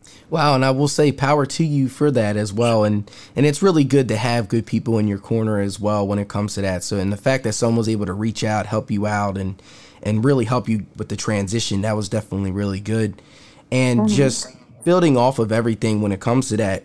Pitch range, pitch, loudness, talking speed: 105-125 Hz, 110 Hz, -20 LUFS, 245 wpm